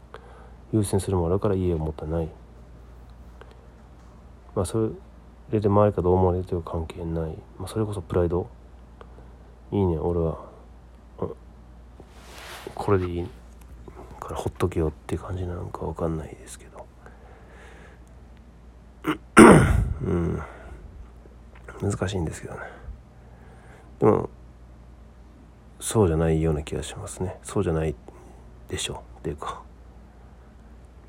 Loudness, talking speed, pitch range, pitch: -24 LUFS, 230 characters per minute, 60-90 Hz, 75 Hz